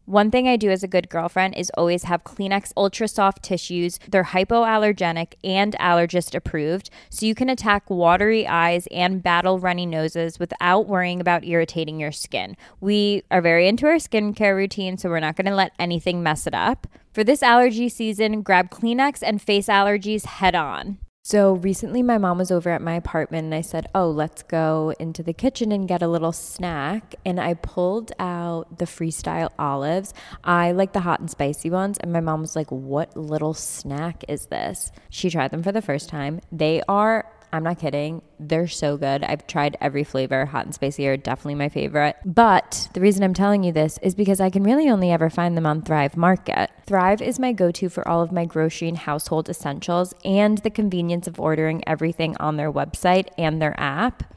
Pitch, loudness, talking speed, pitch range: 175 Hz, -21 LUFS, 200 wpm, 160-200 Hz